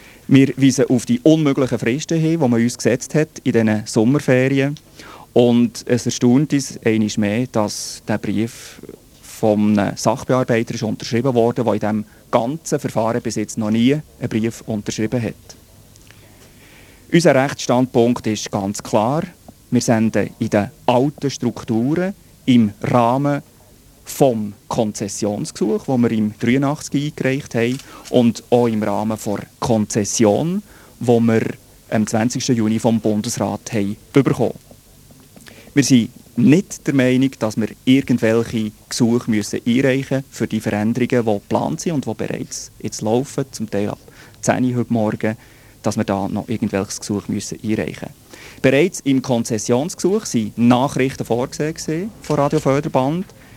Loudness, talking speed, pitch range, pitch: -18 LUFS, 140 wpm, 110-130 Hz, 120 Hz